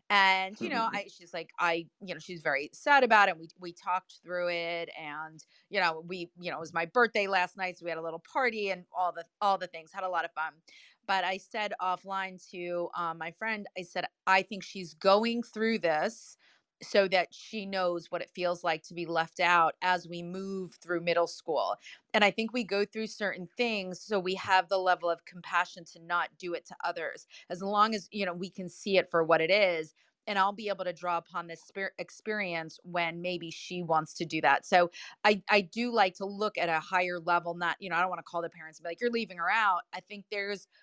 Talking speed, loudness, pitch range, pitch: 240 wpm, -30 LUFS, 170-200 Hz, 180 Hz